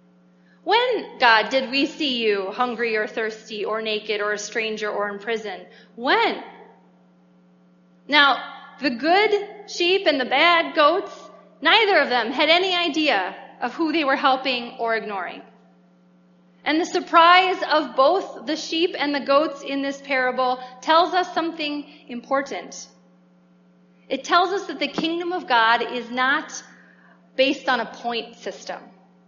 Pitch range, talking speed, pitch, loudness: 210-315 Hz, 145 wpm, 255 Hz, -21 LUFS